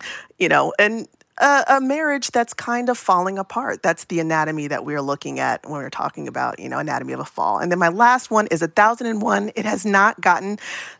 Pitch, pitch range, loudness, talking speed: 210 Hz, 170-240 Hz, -20 LUFS, 230 wpm